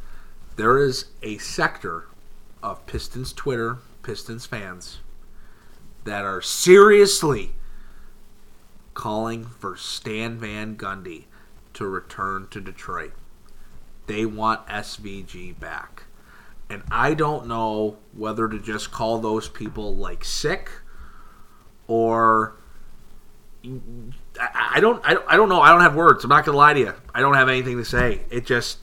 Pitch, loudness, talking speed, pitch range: 110 Hz, -19 LUFS, 130 wpm, 105-120 Hz